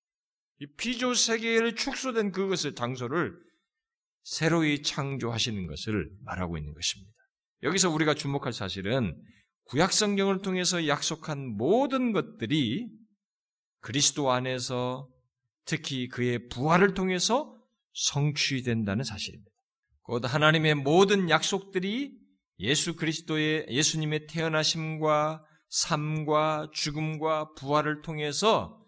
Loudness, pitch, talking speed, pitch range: -28 LUFS, 155 Hz, 265 characters per minute, 130-190 Hz